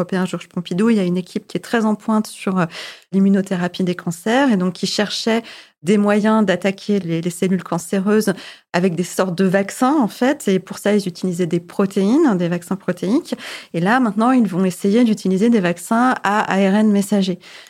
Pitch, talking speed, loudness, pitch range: 195 Hz, 185 wpm, -18 LUFS, 180-215 Hz